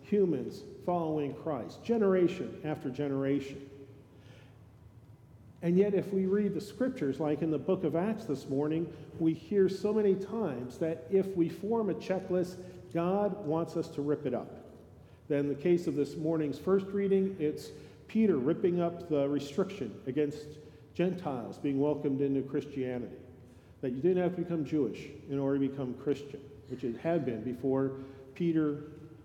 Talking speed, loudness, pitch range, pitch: 160 wpm, -32 LUFS, 135-180 Hz, 150 Hz